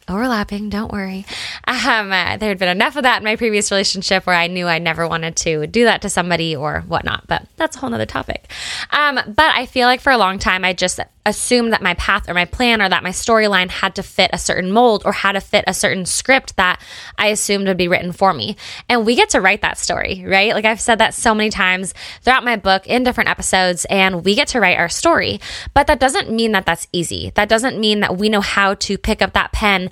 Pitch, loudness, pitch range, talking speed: 200 Hz, -16 LUFS, 185-230 Hz, 250 wpm